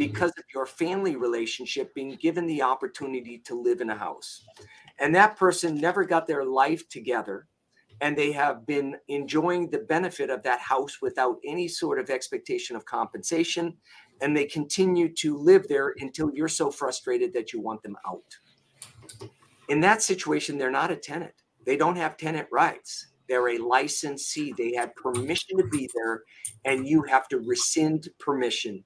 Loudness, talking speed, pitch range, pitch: -26 LUFS, 170 wpm, 140-215 Hz, 160 Hz